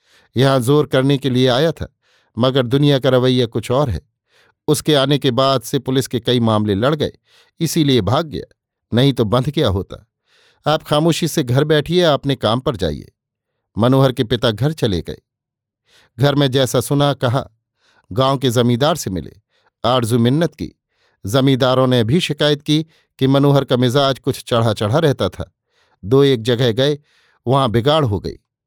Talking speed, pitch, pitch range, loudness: 175 wpm, 135 Hz, 120-145 Hz, -16 LUFS